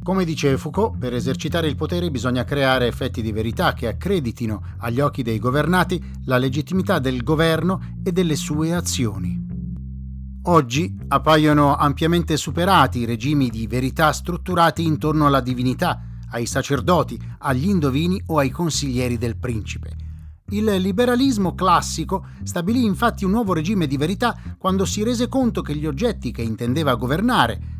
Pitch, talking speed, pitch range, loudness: 140 Hz, 145 wpm, 115-170 Hz, -20 LUFS